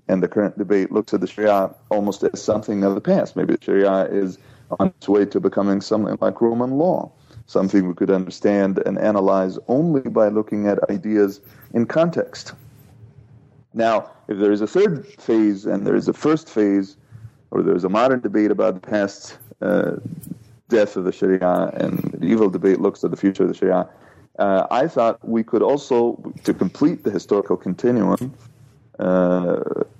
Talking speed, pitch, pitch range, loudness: 180 wpm, 105 Hz, 100-120 Hz, -20 LUFS